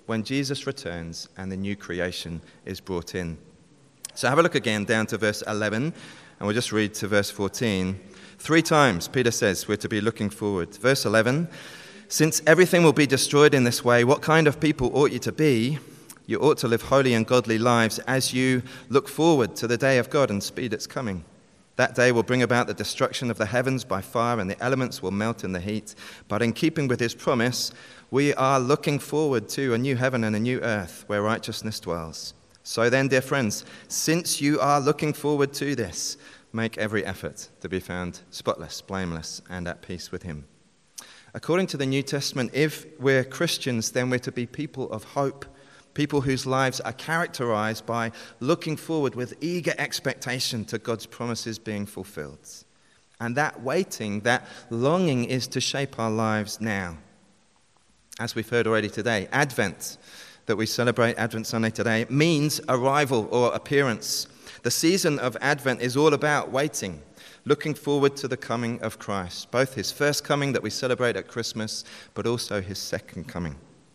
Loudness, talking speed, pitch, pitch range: -25 LUFS, 185 wpm, 120 Hz, 110-140 Hz